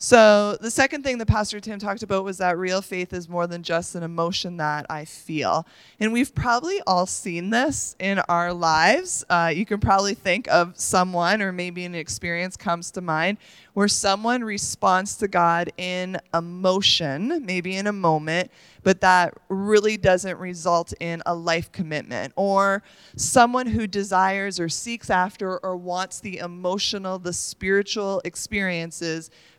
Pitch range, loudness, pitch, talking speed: 175-205 Hz, -23 LUFS, 185 Hz, 160 wpm